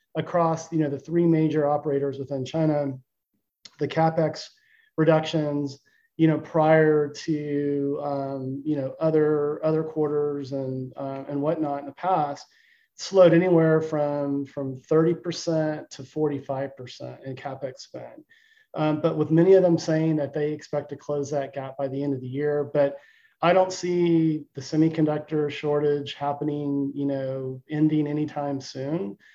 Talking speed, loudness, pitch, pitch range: 145 wpm, -25 LUFS, 150 Hz, 140-160 Hz